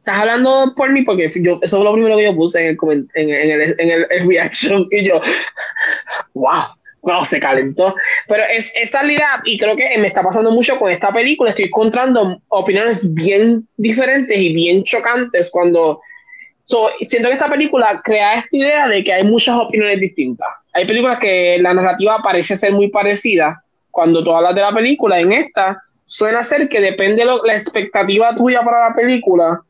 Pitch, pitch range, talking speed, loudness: 215 Hz, 185-245 Hz, 190 wpm, -13 LUFS